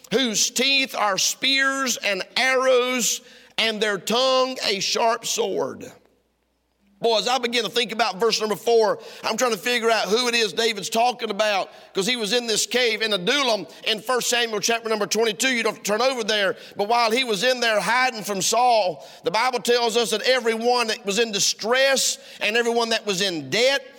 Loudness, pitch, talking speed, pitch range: -21 LUFS, 235 Hz, 195 wpm, 215-250 Hz